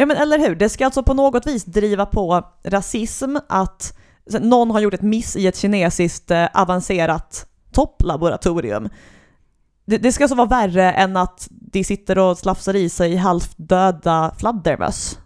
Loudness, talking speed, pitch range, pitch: -18 LUFS, 155 wpm, 180-225 Hz, 195 Hz